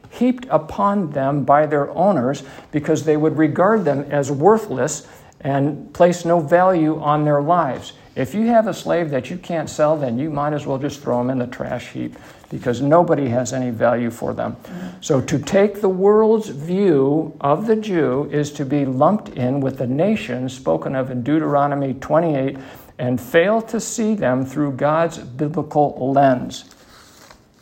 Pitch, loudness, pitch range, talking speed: 150 Hz, -19 LUFS, 135-170 Hz, 170 wpm